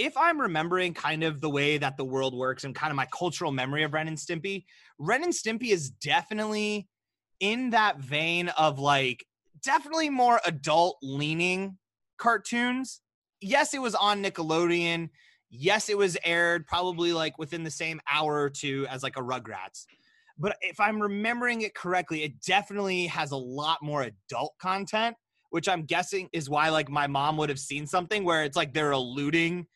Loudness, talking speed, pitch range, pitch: -28 LUFS, 175 wpm, 150-200 Hz, 170 Hz